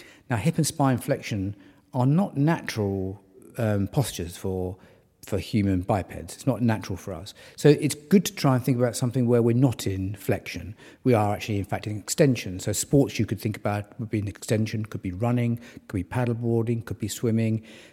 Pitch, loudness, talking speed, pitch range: 110 Hz, -26 LUFS, 200 wpm, 100-125 Hz